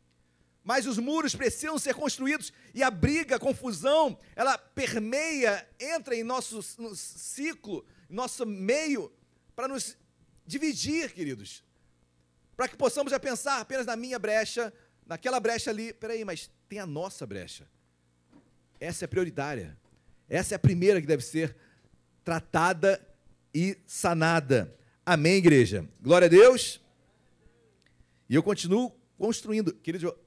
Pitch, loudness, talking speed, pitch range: 210 Hz, -28 LUFS, 130 wpm, 160-255 Hz